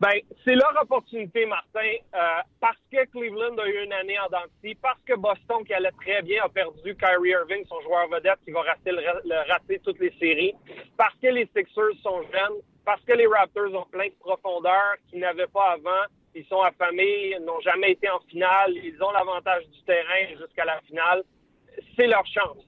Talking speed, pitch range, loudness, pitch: 200 wpm, 180-230 Hz, -24 LUFS, 195 Hz